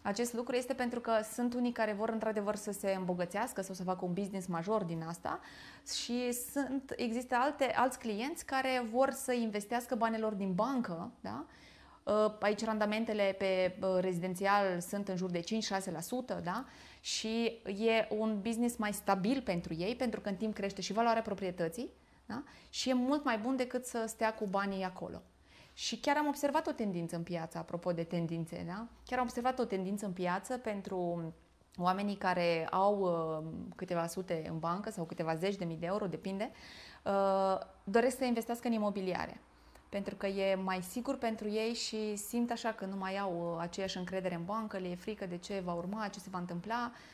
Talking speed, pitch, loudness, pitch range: 180 wpm, 205 Hz, -36 LUFS, 185-235 Hz